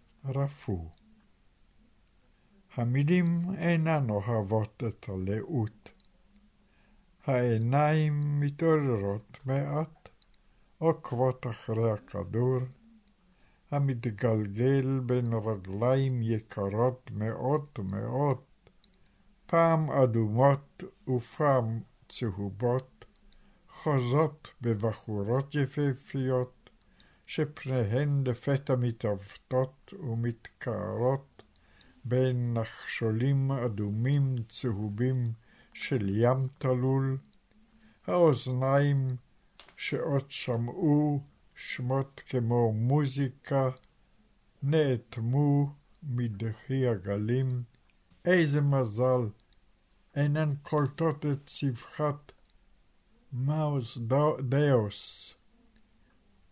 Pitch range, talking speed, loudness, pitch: 115-145 Hz, 55 wpm, -30 LUFS, 130 Hz